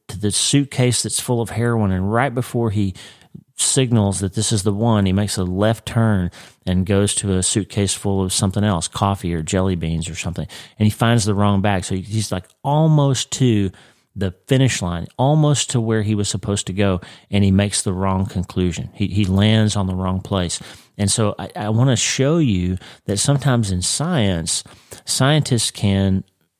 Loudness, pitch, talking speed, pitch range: -19 LUFS, 105 Hz, 195 wpm, 95-115 Hz